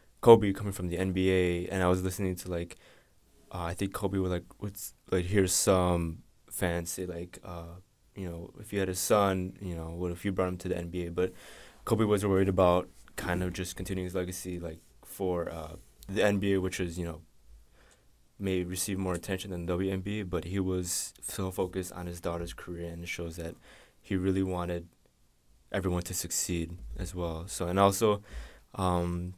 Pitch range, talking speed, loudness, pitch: 85-95 Hz, 195 wpm, -31 LUFS, 90 Hz